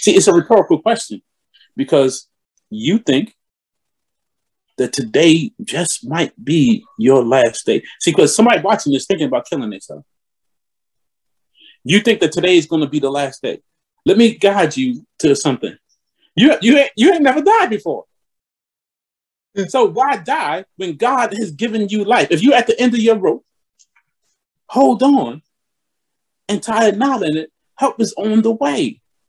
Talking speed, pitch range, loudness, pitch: 165 wpm, 185-265 Hz, -15 LUFS, 225 Hz